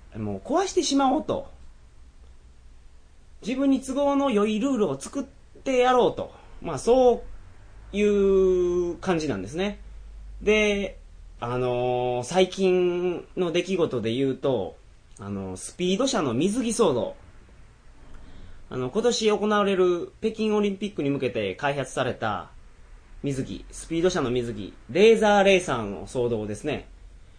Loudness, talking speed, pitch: -24 LUFS, 240 characters per minute, 165 Hz